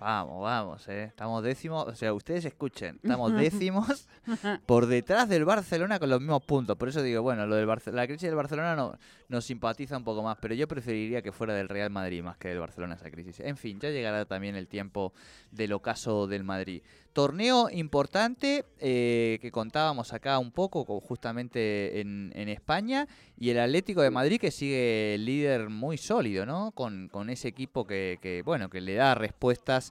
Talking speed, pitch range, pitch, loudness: 190 wpm, 105-145 Hz, 120 Hz, -30 LUFS